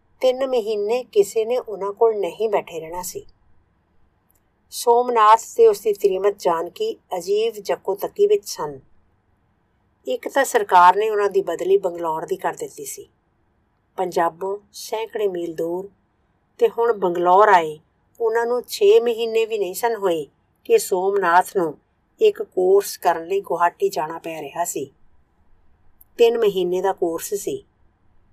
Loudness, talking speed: -20 LUFS, 140 wpm